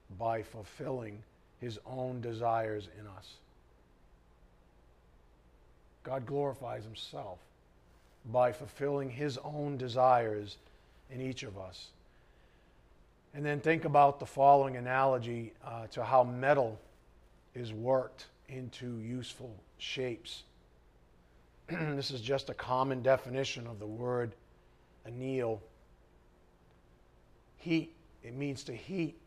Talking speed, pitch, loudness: 105 wpm, 115 Hz, -34 LUFS